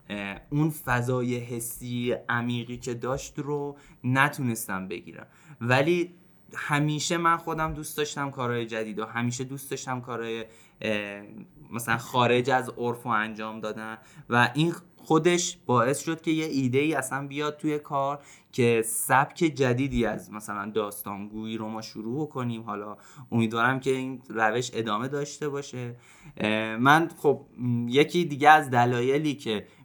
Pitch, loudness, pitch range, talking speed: 125 Hz, -27 LUFS, 115-145 Hz, 135 wpm